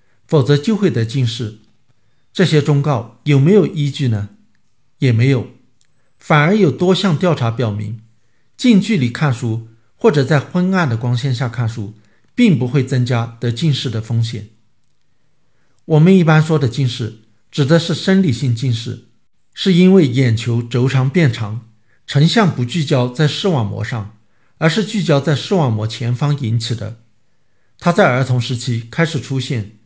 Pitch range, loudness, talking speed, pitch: 115-155 Hz, -15 LUFS, 230 characters per minute, 130 Hz